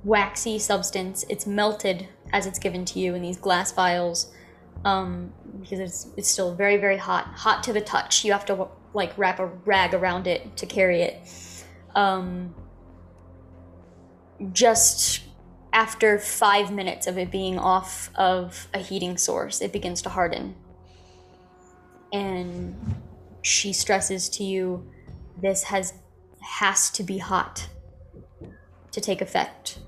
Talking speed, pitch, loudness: 135 wpm, 180 Hz, -24 LUFS